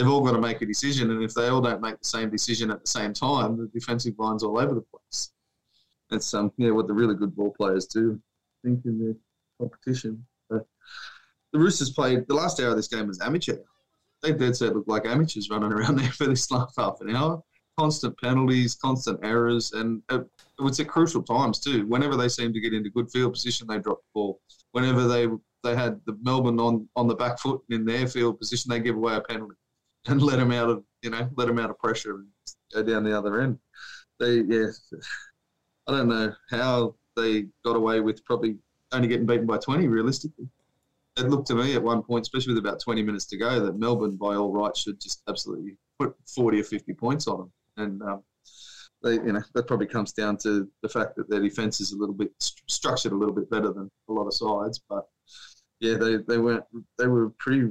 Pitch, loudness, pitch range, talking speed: 115 Hz, -26 LUFS, 110-125 Hz, 225 wpm